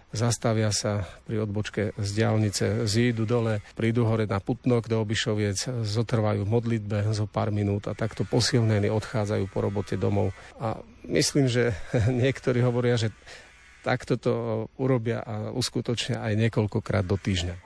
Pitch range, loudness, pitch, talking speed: 105-120 Hz, -26 LUFS, 110 Hz, 145 wpm